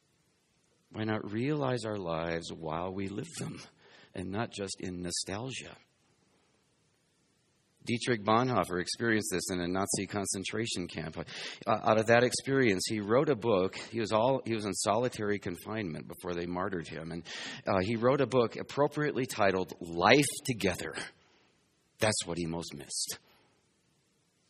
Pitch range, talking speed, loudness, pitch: 90-115 Hz, 145 wpm, -32 LUFS, 100 Hz